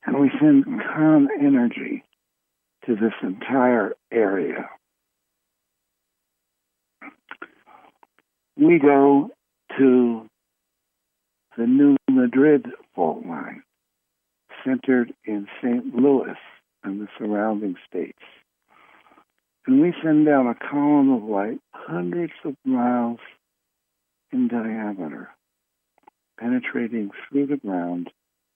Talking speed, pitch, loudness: 90 wpm, 115 Hz, -21 LUFS